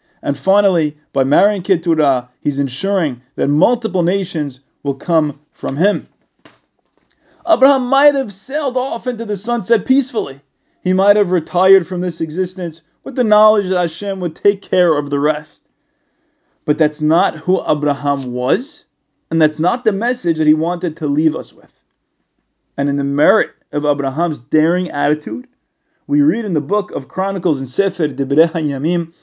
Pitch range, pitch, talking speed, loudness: 150-210 Hz, 175 Hz, 160 wpm, -16 LUFS